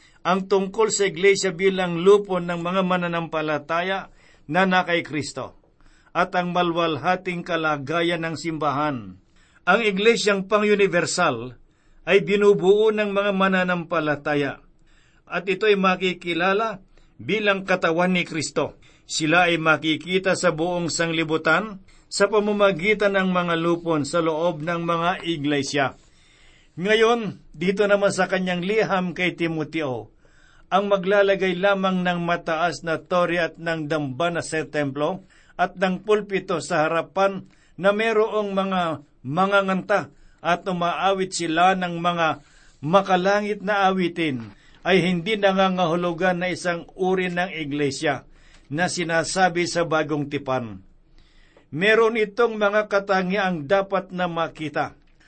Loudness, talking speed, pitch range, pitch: -22 LUFS, 115 wpm, 160-195 Hz, 175 Hz